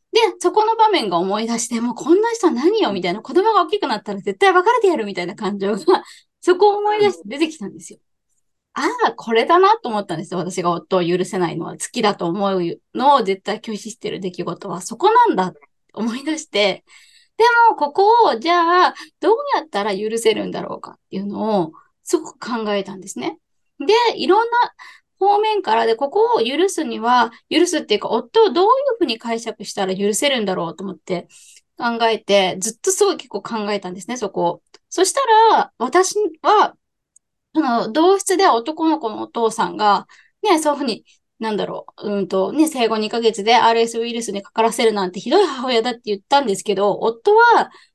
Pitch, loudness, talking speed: 230 Hz, -18 LUFS, 380 characters per minute